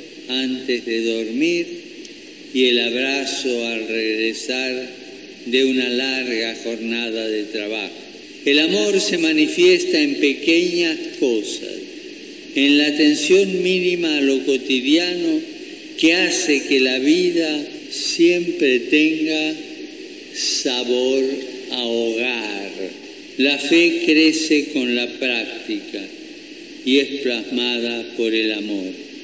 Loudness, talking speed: -18 LUFS, 105 wpm